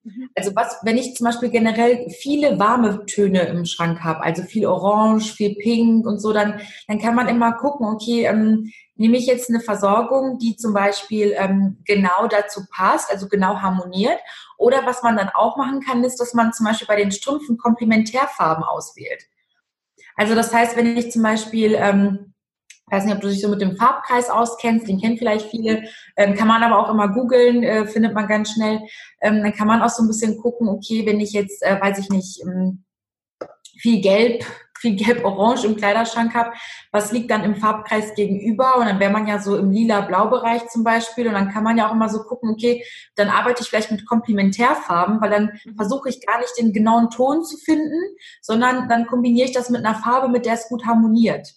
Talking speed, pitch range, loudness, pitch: 200 wpm, 205-240 Hz, -19 LUFS, 225 Hz